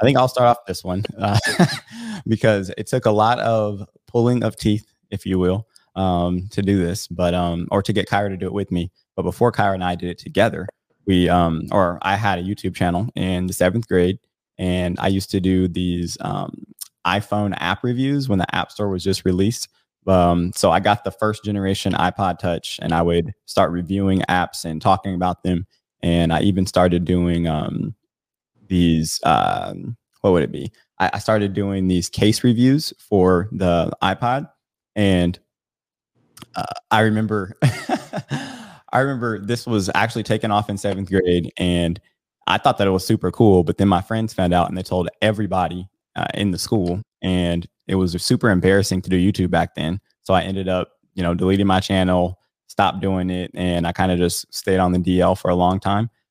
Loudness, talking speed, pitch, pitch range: -20 LUFS, 195 wpm, 95 Hz, 90-105 Hz